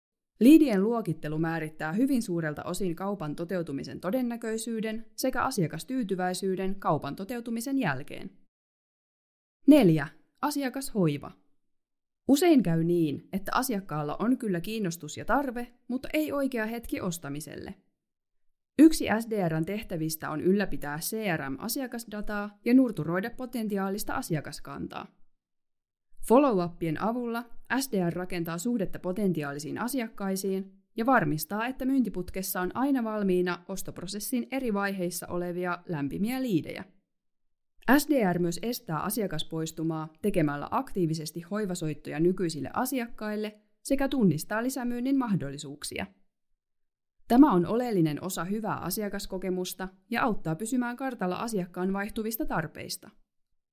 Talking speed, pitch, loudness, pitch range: 95 wpm, 195 Hz, -29 LUFS, 170-235 Hz